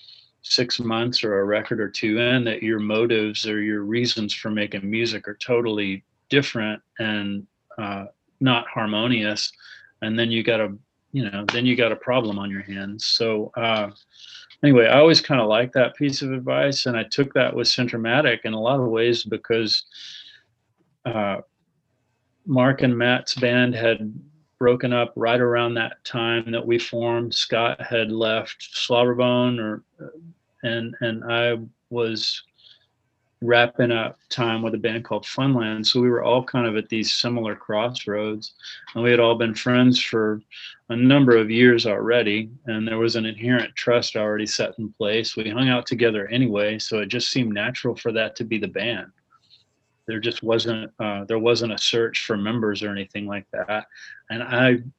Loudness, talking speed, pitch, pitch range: -22 LUFS, 175 wpm, 115 Hz, 110-125 Hz